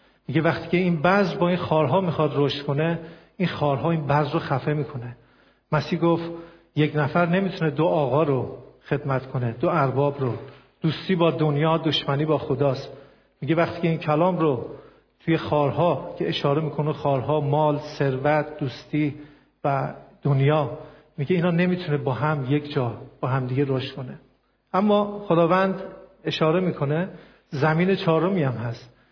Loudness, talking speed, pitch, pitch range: -23 LUFS, 150 wpm, 150 Hz, 140-165 Hz